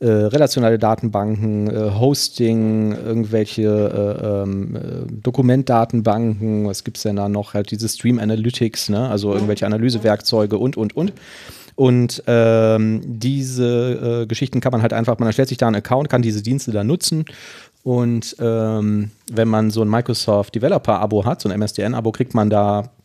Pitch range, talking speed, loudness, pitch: 105-120 Hz, 165 wpm, -18 LUFS, 115 Hz